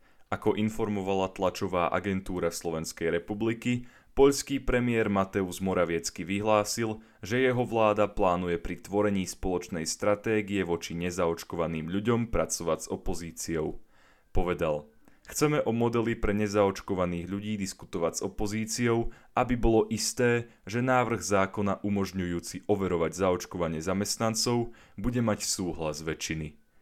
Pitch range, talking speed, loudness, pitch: 90-115 Hz, 110 wpm, -29 LUFS, 100 Hz